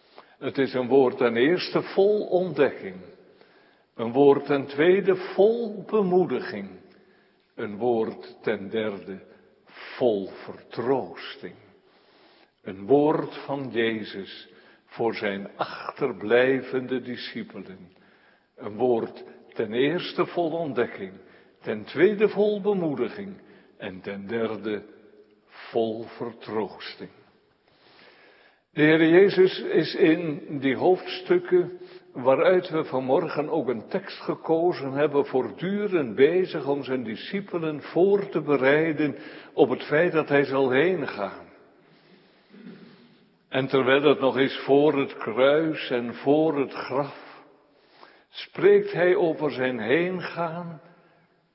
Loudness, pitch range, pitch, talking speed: -24 LUFS, 130-190 Hz, 155 Hz, 105 wpm